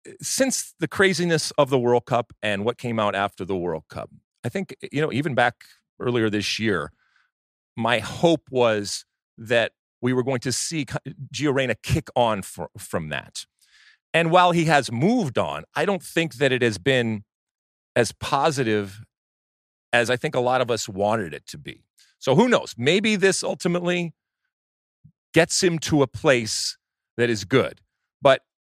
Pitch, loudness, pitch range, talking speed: 130 Hz, -23 LUFS, 110-165 Hz, 165 wpm